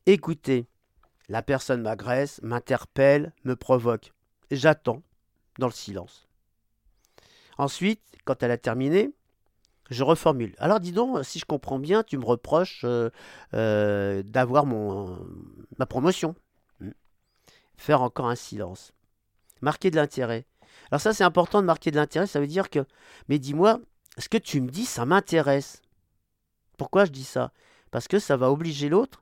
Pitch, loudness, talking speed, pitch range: 130 Hz, -25 LUFS, 150 wpm, 110-155 Hz